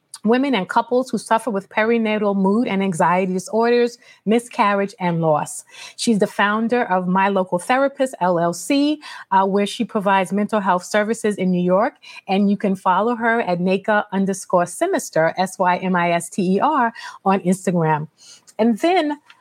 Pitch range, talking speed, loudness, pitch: 185-235 Hz, 165 wpm, -19 LUFS, 205 Hz